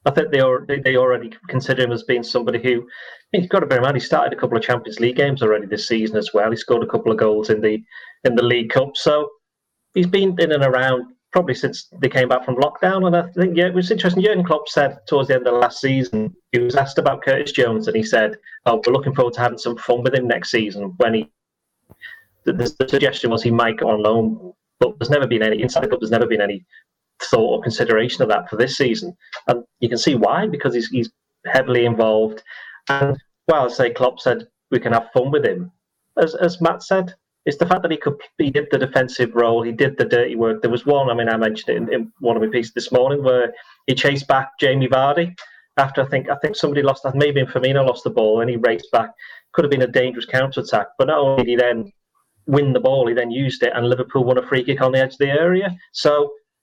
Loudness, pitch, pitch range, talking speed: -18 LUFS, 130 Hz, 115-140 Hz, 250 wpm